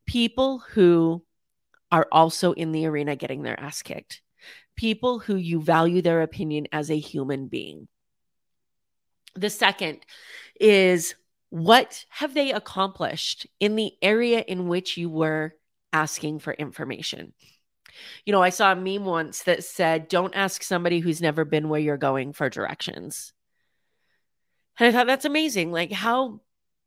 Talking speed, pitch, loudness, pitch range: 145 wpm, 175 Hz, -23 LUFS, 155-210 Hz